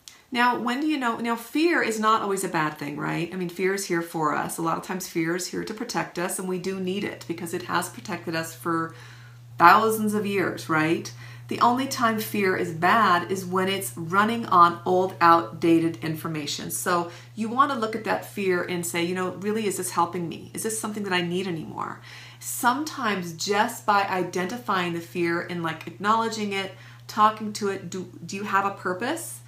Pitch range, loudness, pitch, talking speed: 165-210 Hz, -25 LUFS, 180 Hz, 210 wpm